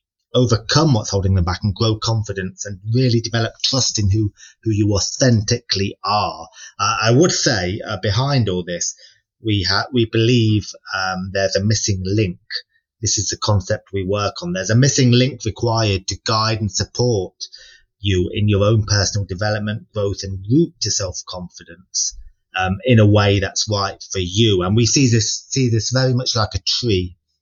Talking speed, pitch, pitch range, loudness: 175 wpm, 105 Hz, 95-115 Hz, -18 LUFS